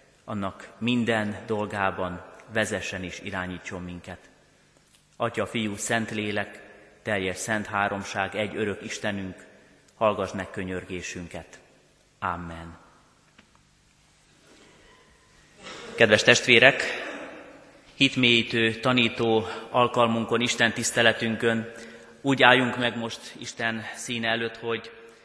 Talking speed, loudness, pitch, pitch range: 85 wpm, -24 LUFS, 110 Hz, 95-115 Hz